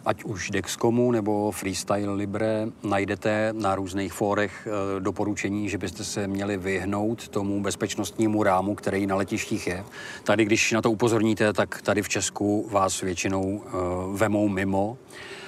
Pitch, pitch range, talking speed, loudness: 105 Hz, 100-110 Hz, 140 wpm, -26 LUFS